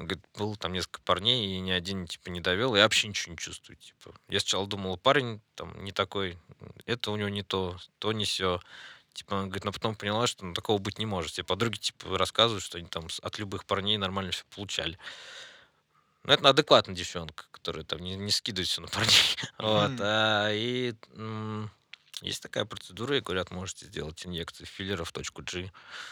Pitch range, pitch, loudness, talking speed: 90-110 Hz, 100 Hz, -29 LUFS, 195 wpm